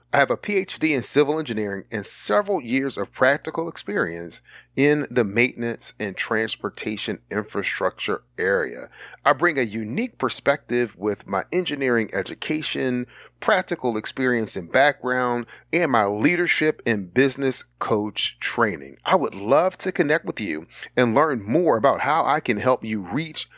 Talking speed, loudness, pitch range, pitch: 145 wpm, -23 LUFS, 110-145 Hz, 125 Hz